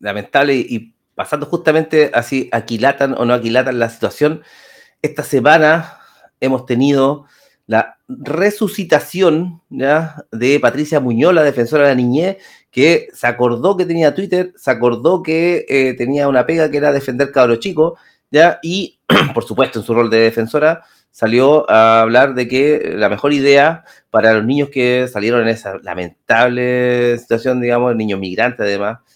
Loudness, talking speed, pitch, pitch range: -14 LUFS, 155 wpm, 135 Hz, 120-155 Hz